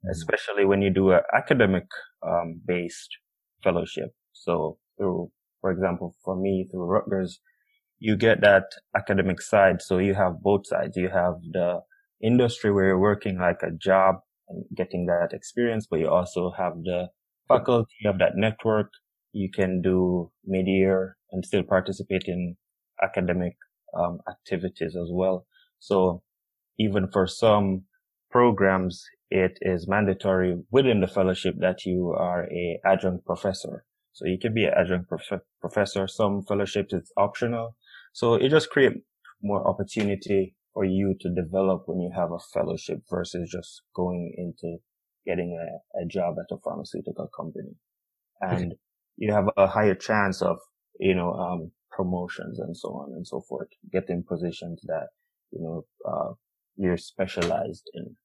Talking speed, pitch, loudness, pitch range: 150 wpm, 95 Hz, -26 LUFS, 90-105 Hz